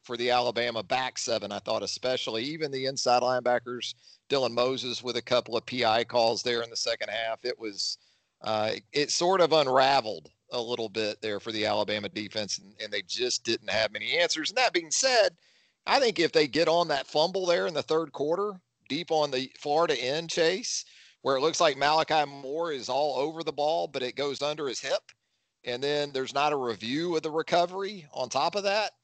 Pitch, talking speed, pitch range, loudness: 135 Hz, 210 wpm, 120-160 Hz, -28 LUFS